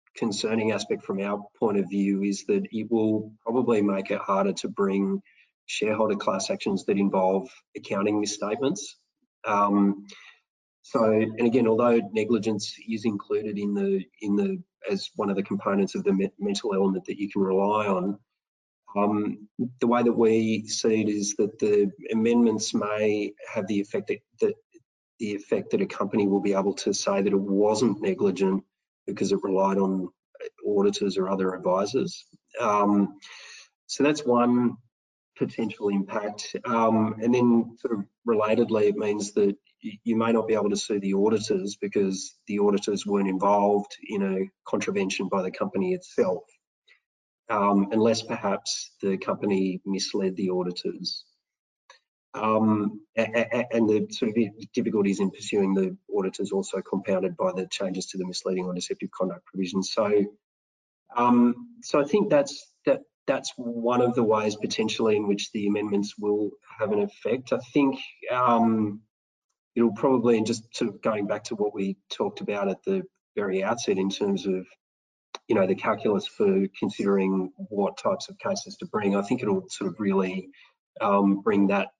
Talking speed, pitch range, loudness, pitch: 160 wpm, 100-120 Hz, -26 LUFS, 105 Hz